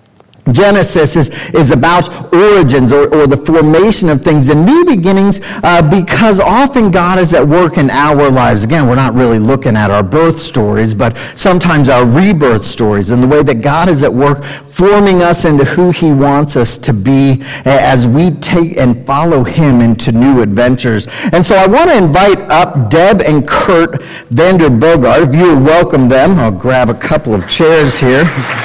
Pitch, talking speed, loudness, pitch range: 150 Hz, 180 wpm, -8 LUFS, 125-175 Hz